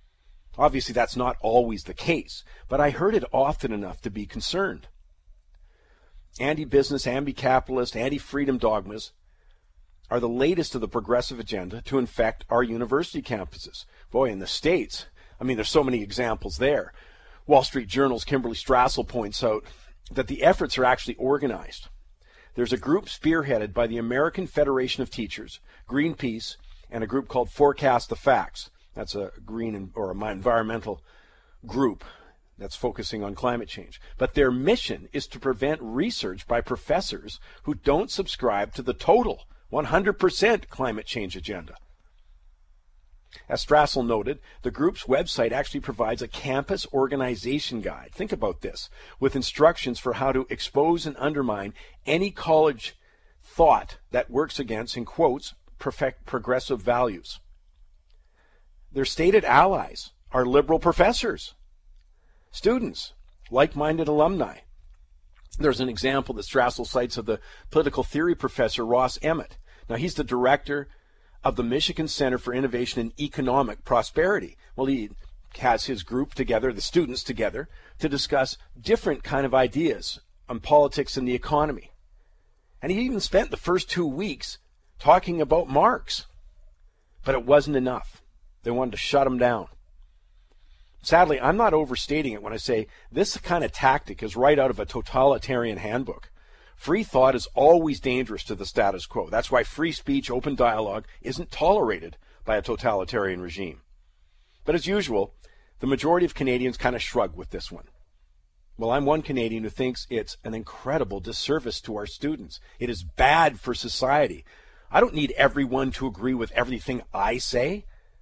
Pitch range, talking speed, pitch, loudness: 105-140 Hz, 150 wpm, 125 Hz, -25 LUFS